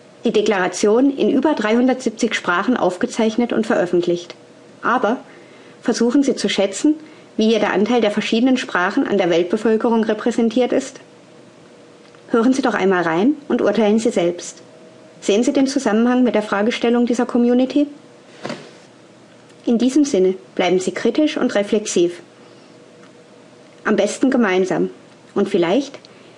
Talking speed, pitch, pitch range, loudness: 130 wpm, 230 Hz, 200-250 Hz, -18 LUFS